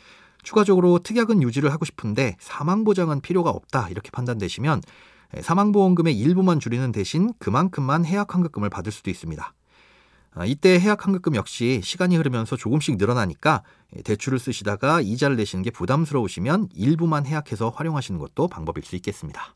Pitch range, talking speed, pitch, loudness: 110-175 Hz, 410 characters per minute, 145 Hz, -22 LUFS